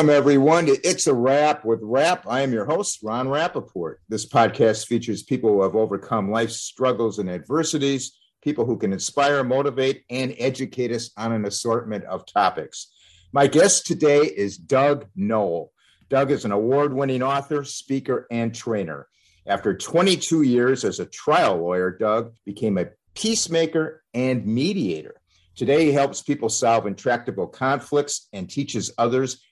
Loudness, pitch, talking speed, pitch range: -22 LUFS, 125 Hz, 150 wpm, 110-140 Hz